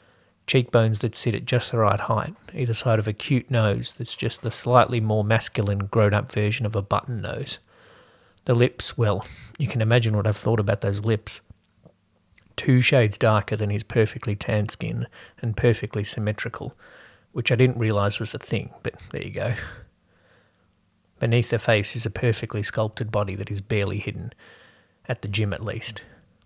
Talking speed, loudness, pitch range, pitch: 175 wpm, -24 LUFS, 105-120 Hz, 110 Hz